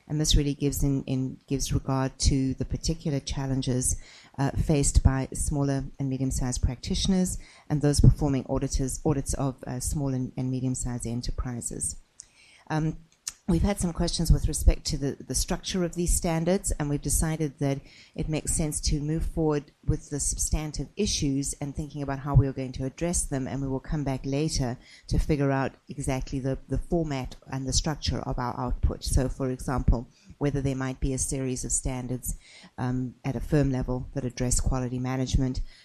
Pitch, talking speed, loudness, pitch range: 135 Hz, 180 wpm, -28 LUFS, 130-150 Hz